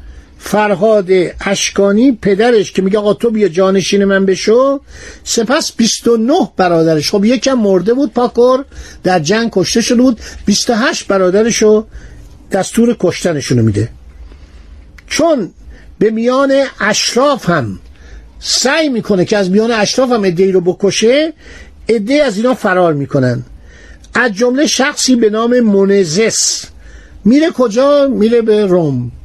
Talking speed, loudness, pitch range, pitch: 125 wpm, -12 LUFS, 175-240 Hz, 205 Hz